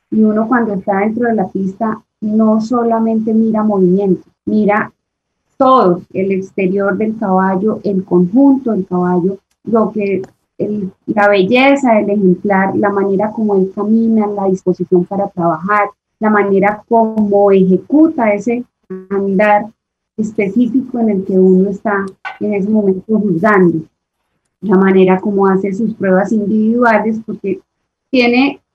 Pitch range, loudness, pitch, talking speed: 190-220 Hz, -13 LUFS, 205 Hz, 130 wpm